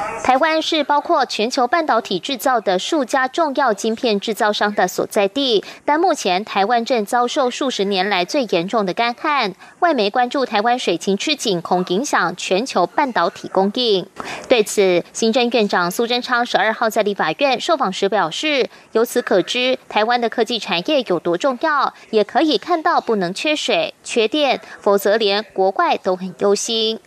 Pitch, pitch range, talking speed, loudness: 225 Hz, 200-275 Hz, 265 characters per minute, -18 LUFS